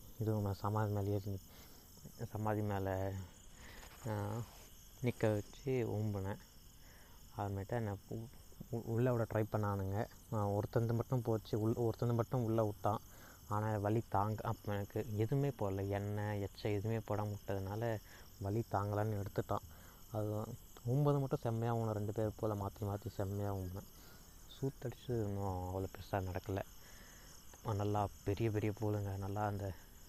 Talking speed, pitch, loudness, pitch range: 125 wpm, 105 Hz, -40 LUFS, 100-115 Hz